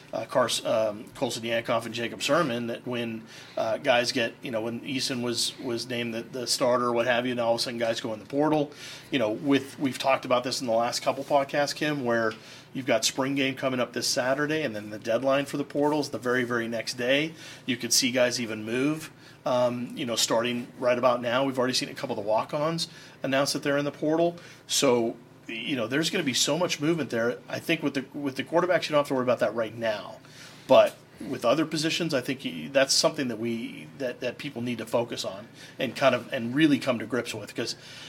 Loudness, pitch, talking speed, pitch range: -27 LUFS, 130 Hz, 240 wpm, 120-145 Hz